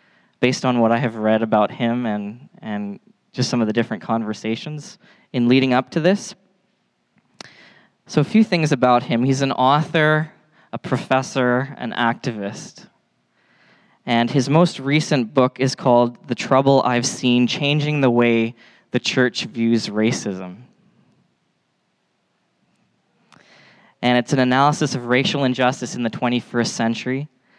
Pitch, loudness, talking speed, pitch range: 125 Hz, -19 LUFS, 135 wpm, 115-145 Hz